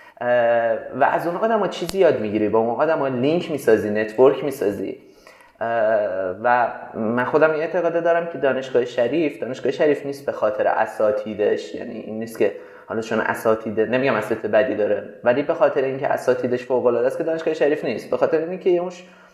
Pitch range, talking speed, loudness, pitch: 115-165 Hz, 175 wpm, -21 LUFS, 130 Hz